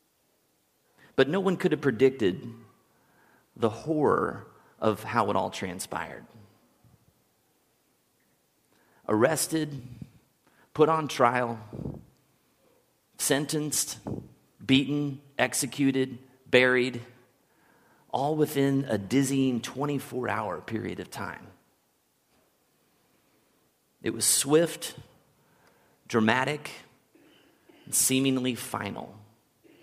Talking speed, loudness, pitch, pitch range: 75 wpm, -27 LUFS, 130 Hz, 115-140 Hz